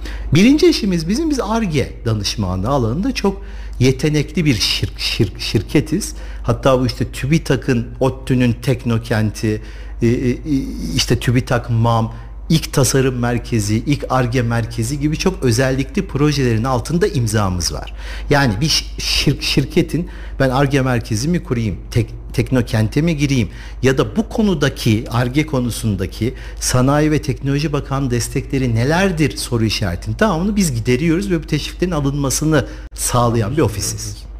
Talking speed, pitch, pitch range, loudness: 125 wpm, 130 Hz, 115-150 Hz, -17 LUFS